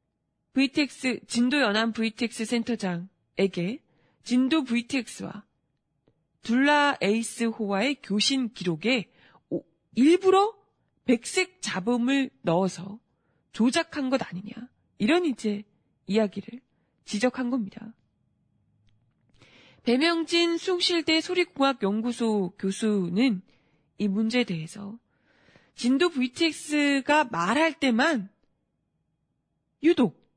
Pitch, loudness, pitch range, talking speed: 235 Hz, -26 LUFS, 195-275 Hz, 205 characters per minute